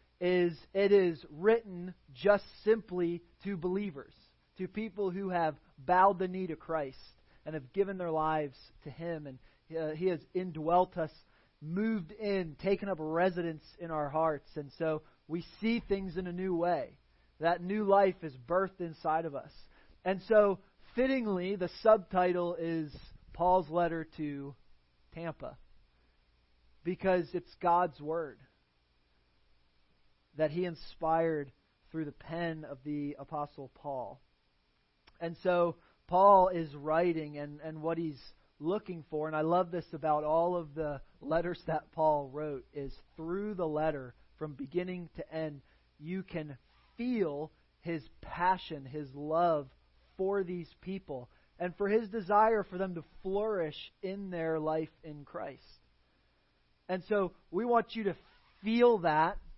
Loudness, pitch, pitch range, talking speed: -33 LUFS, 165 Hz, 150-185 Hz, 140 wpm